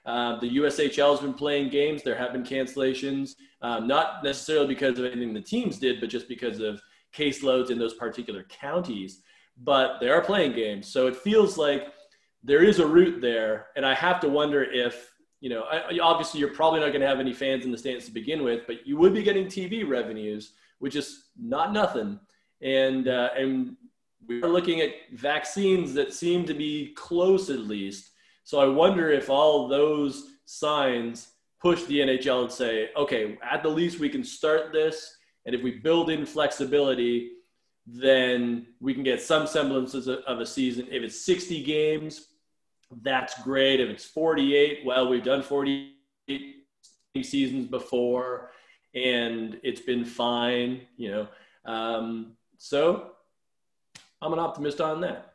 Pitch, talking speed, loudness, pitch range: 140 Hz, 170 wpm, -26 LUFS, 125-160 Hz